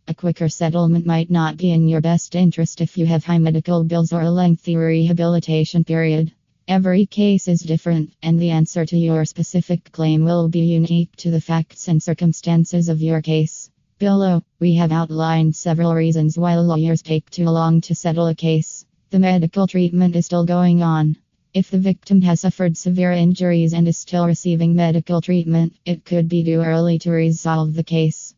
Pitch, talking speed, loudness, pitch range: 165 Hz, 185 wpm, -18 LUFS, 160-175 Hz